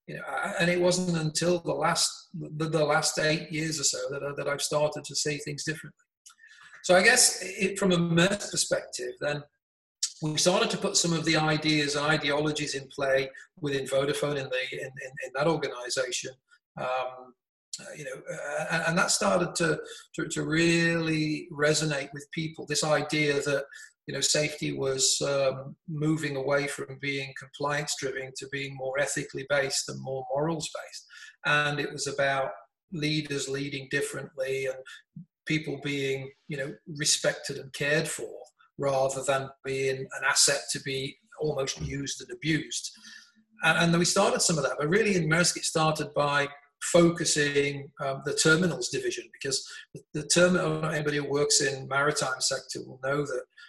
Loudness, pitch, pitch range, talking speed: -27 LUFS, 150 Hz, 140-170 Hz, 165 wpm